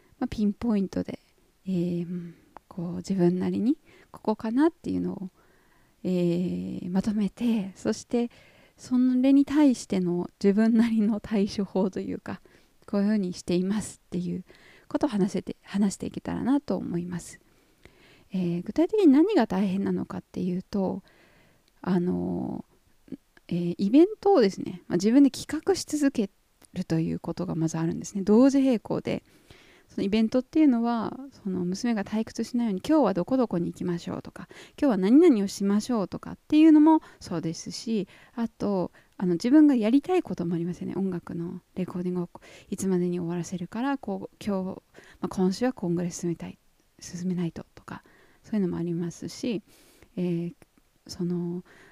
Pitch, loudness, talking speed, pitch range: 195 Hz, -26 LUFS, 345 characters per minute, 175-240 Hz